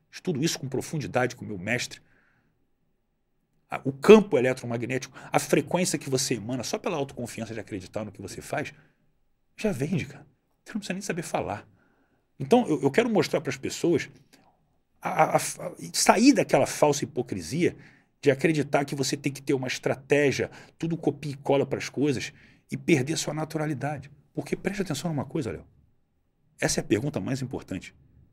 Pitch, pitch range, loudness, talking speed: 145 Hz, 130-165 Hz, -26 LUFS, 170 wpm